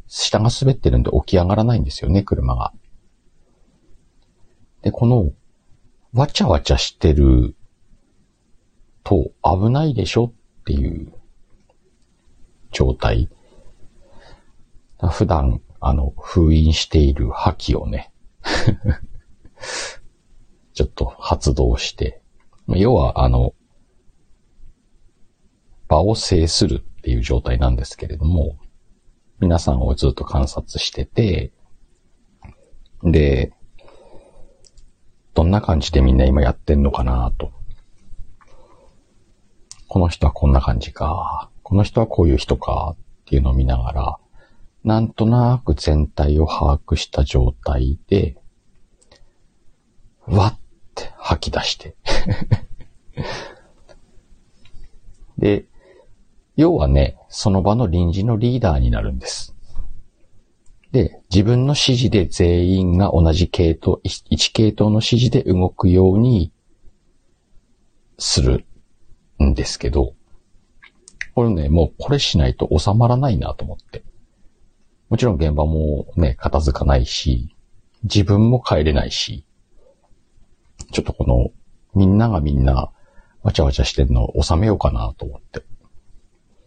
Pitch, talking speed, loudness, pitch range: 90 Hz, 215 characters per minute, -18 LUFS, 70-105 Hz